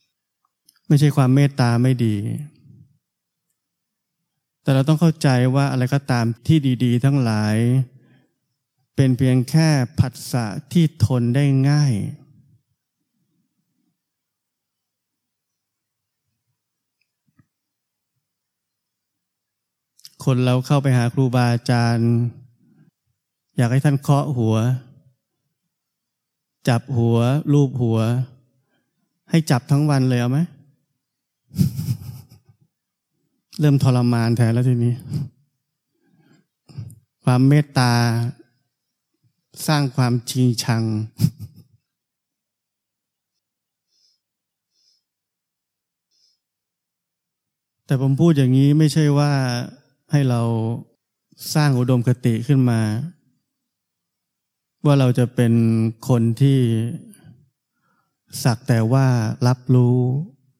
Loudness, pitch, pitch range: -19 LUFS, 130 Hz, 120-145 Hz